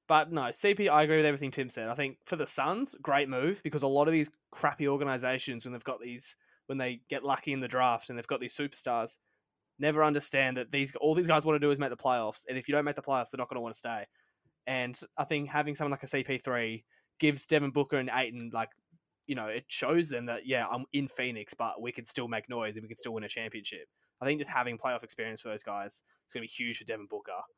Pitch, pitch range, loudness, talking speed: 135 Hz, 120-150 Hz, -32 LUFS, 265 wpm